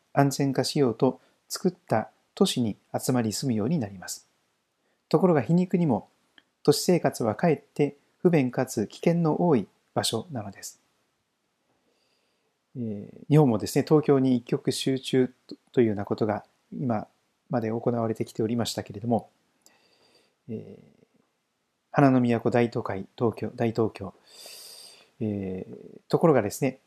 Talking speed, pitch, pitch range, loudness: 270 characters per minute, 125 Hz, 110-145 Hz, -26 LUFS